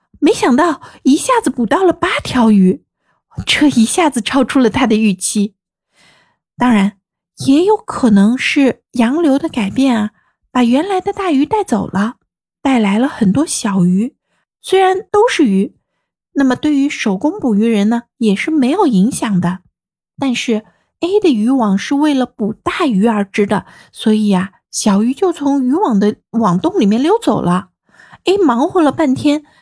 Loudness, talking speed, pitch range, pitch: -14 LUFS, 230 characters per minute, 210-300 Hz, 250 Hz